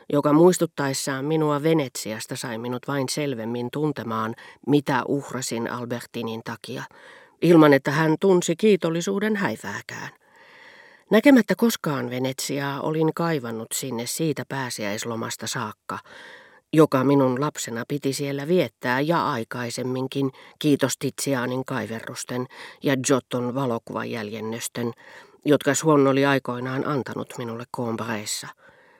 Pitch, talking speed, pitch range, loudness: 135 Hz, 100 wpm, 120-155 Hz, -24 LUFS